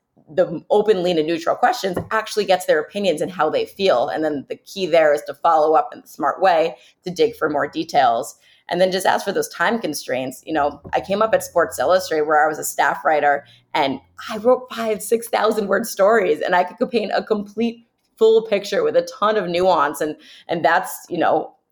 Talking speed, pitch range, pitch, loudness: 220 wpm, 165-230 Hz, 195 Hz, -19 LUFS